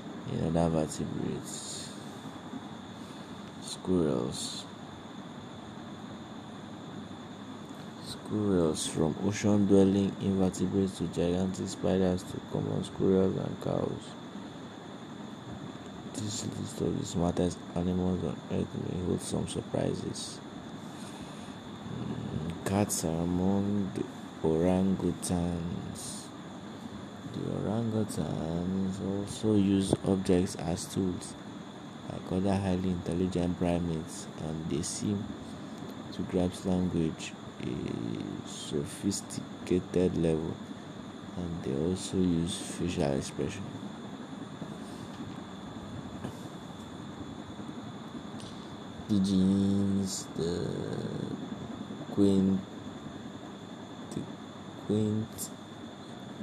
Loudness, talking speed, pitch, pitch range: -32 LUFS, 70 wpm, 95 Hz, 85-100 Hz